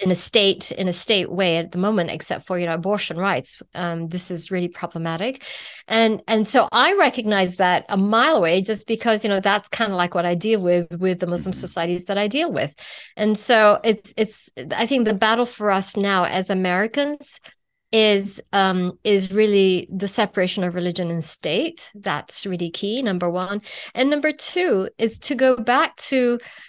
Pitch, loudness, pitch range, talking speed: 200 Hz, -20 LUFS, 180-225 Hz, 195 wpm